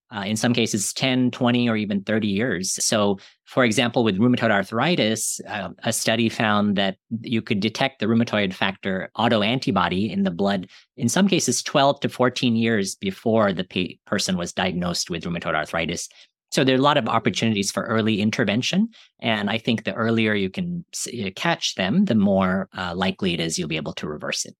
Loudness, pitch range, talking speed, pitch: -22 LUFS, 105-125 Hz, 195 wpm, 115 Hz